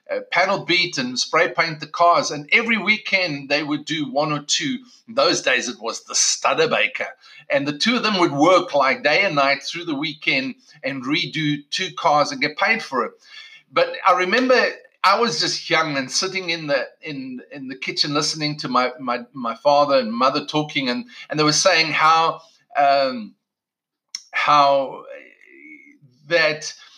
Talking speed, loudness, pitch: 180 wpm, -19 LUFS, 170 Hz